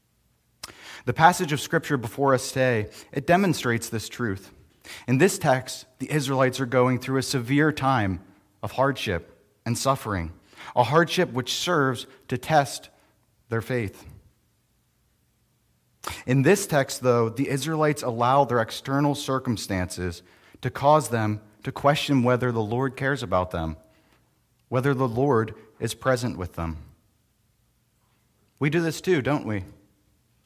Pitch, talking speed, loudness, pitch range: 125 Hz, 135 wpm, -24 LUFS, 105-140 Hz